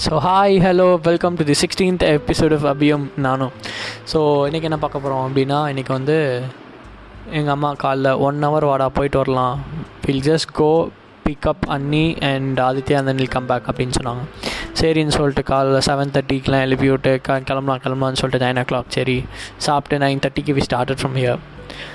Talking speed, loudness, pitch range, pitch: 160 wpm, -18 LUFS, 130-150 Hz, 135 Hz